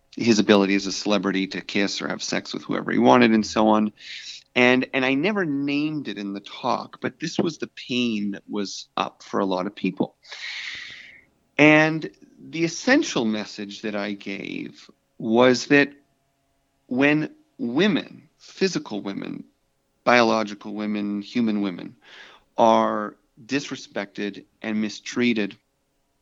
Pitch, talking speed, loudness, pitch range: 115 Hz, 135 wpm, -23 LUFS, 105-140 Hz